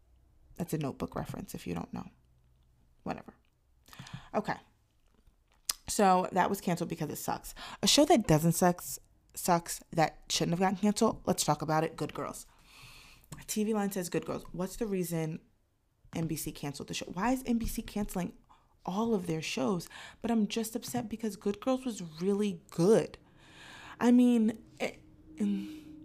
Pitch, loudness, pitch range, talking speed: 190 Hz, -32 LUFS, 160-225 Hz, 155 wpm